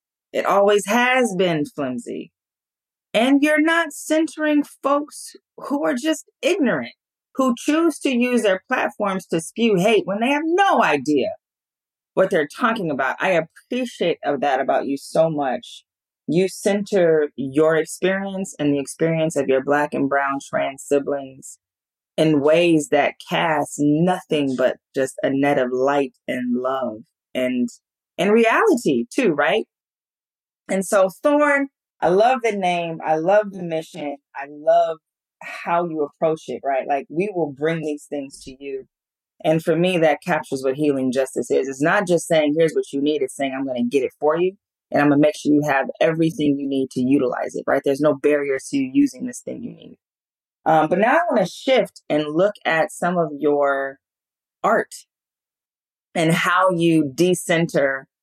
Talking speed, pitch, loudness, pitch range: 170 wpm, 160 Hz, -20 LUFS, 145-210 Hz